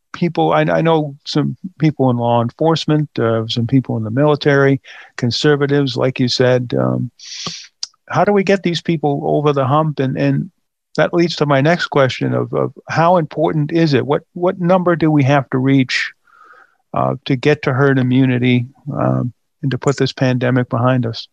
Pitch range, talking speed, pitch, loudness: 125-155 Hz, 185 wpm, 140 Hz, -16 LUFS